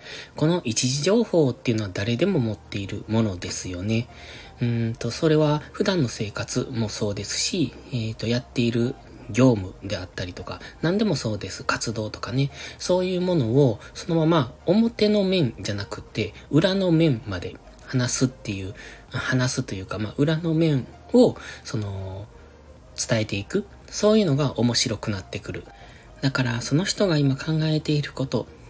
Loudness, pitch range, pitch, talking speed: -24 LUFS, 110-155 Hz, 125 Hz, 315 characters per minute